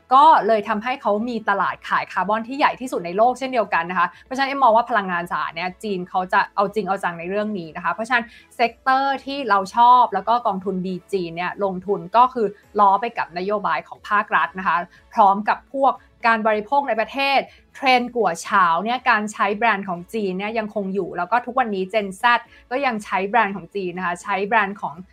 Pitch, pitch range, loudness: 215 Hz, 195-245 Hz, -20 LUFS